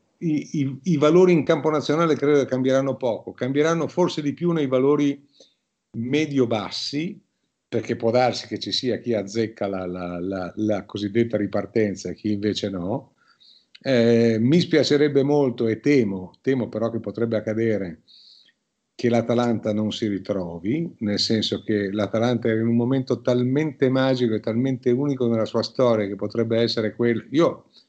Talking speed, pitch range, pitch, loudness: 160 wpm, 105-140 Hz, 115 Hz, -22 LUFS